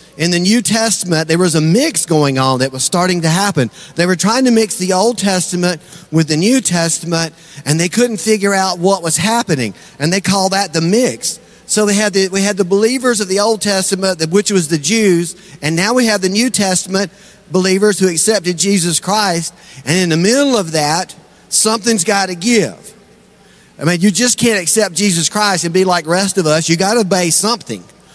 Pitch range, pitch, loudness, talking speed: 170-210 Hz, 190 Hz, -13 LUFS, 215 wpm